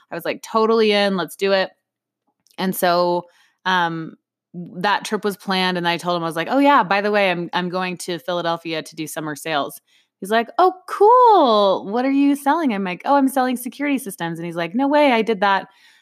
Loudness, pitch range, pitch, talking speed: -19 LUFS, 175-250 Hz, 195 Hz, 220 wpm